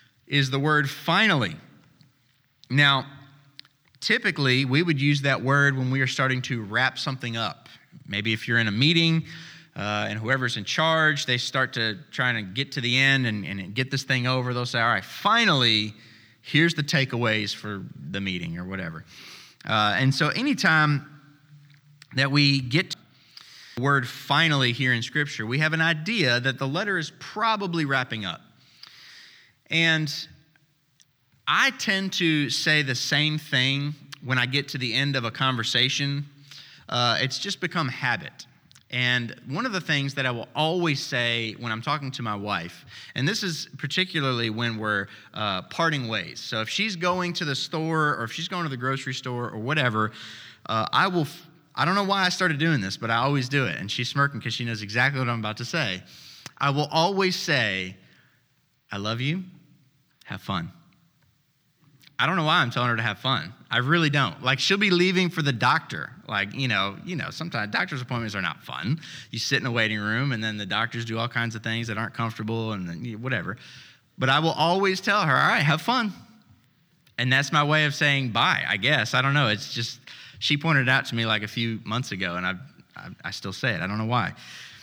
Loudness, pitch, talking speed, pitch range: -24 LUFS, 135 Hz, 200 wpm, 115-150 Hz